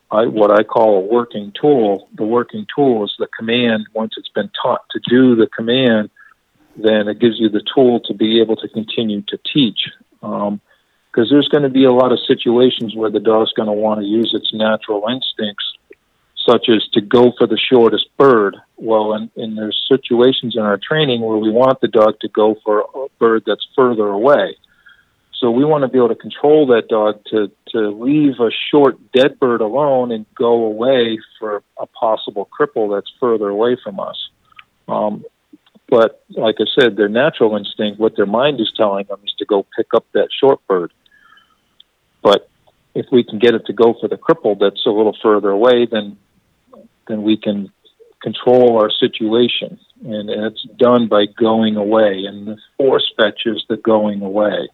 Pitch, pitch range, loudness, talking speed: 110 Hz, 105-125 Hz, -15 LUFS, 190 wpm